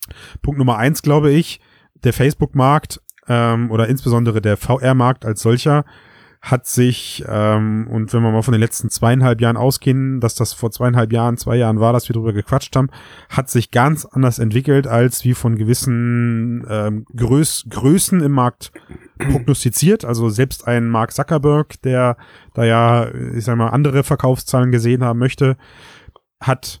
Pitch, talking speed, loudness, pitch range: 120 Hz, 160 wpm, -16 LUFS, 115-130 Hz